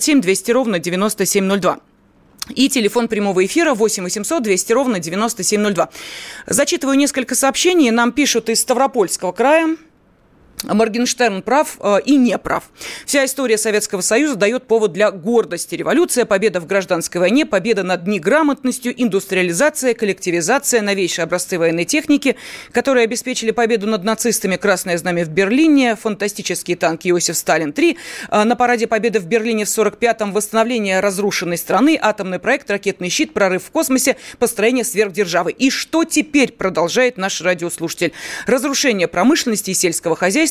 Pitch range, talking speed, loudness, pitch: 190-255 Hz, 135 wpm, -16 LUFS, 220 Hz